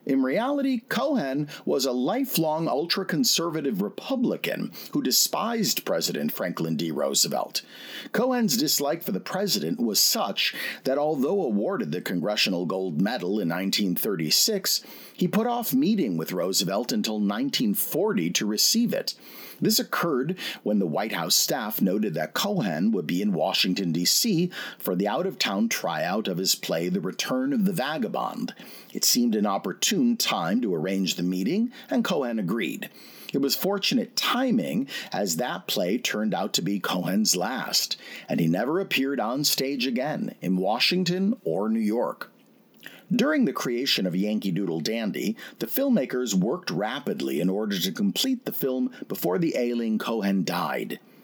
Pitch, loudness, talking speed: 195 Hz, -25 LUFS, 150 wpm